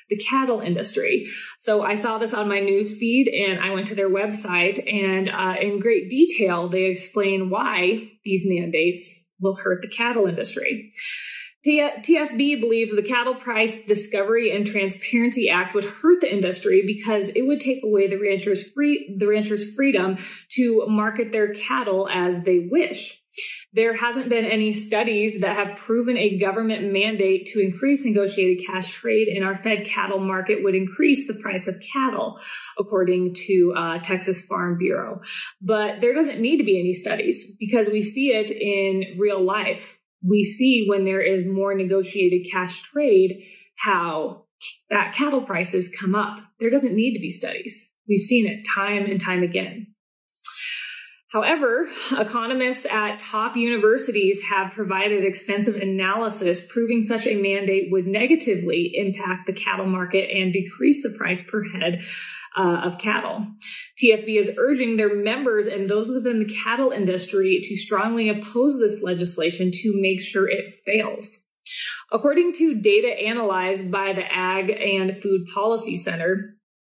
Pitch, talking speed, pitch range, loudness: 205 Hz, 155 wpm, 190-230 Hz, -22 LUFS